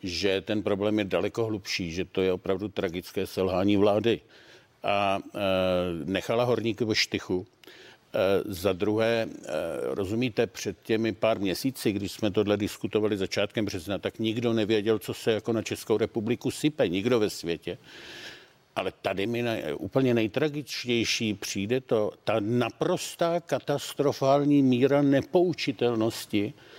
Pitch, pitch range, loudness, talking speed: 110 Hz, 100-120 Hz, -27 LUFS, 135 wpm